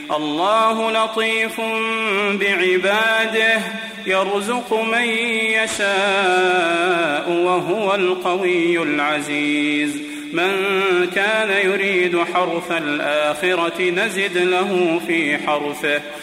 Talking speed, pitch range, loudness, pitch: 65 wpm, 170-220 Hz, -18 LUFS, 185 Hz